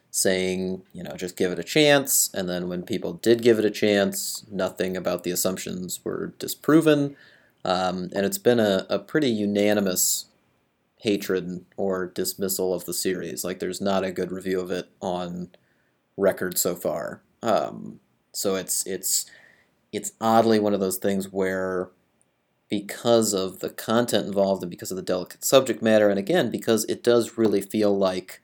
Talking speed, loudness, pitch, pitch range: 170 wpm, -24 LUFS, 95 Hz, 90-110 Hz